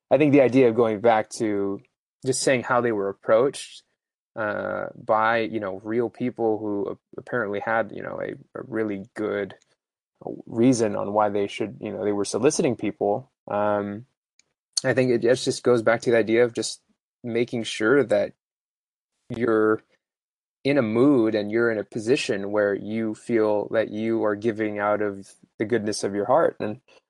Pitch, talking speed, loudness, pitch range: 110 Hz, 175 wpm, -24 LUFS, 105-120 Hz